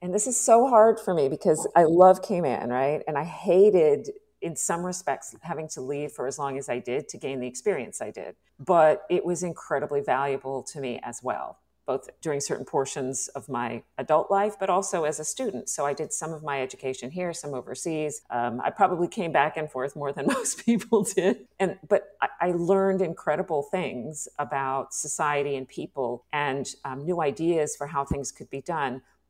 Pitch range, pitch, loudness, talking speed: 140-185 Hz, 155 Hz, -26 LUFS, 200 wpm